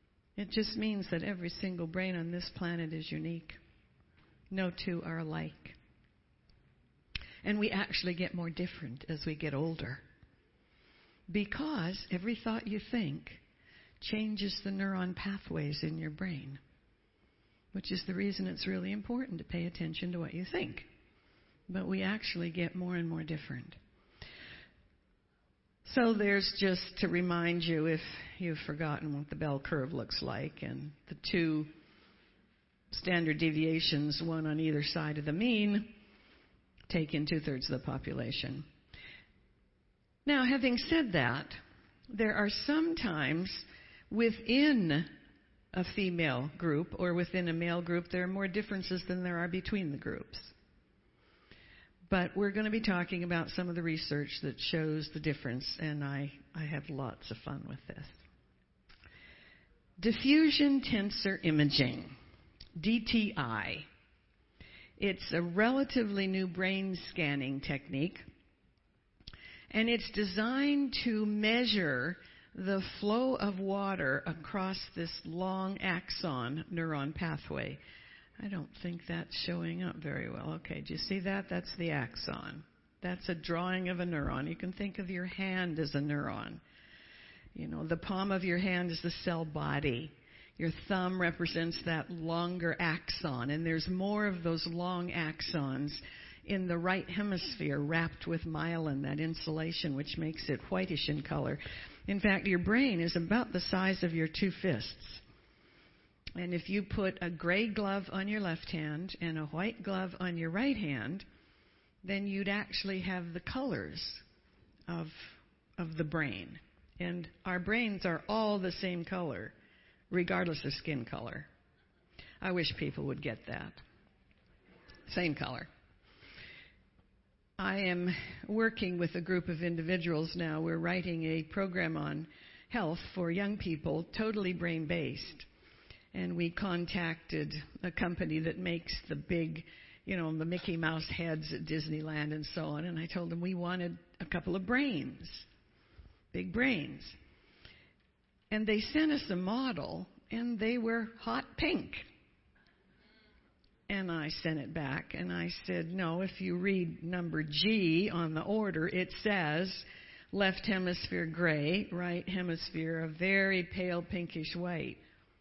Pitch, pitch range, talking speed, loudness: 175 Hz, 160-195 Hz, 145 wpm, -35 LUFS